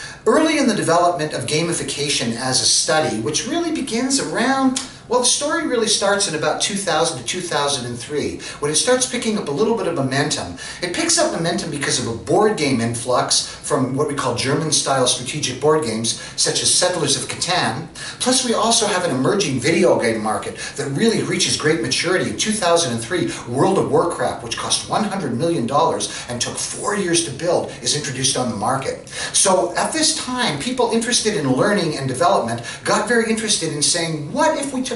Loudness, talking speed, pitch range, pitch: -18 LUFS, 190 wpm, 140-230 Hz, 165 Hz